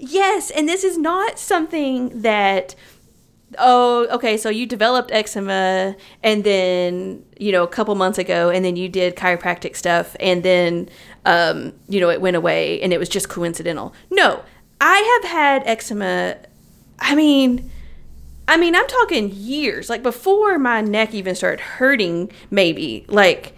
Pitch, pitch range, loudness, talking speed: 215 Hz, 185-280 Hz, -18 LUFS, 155 wpm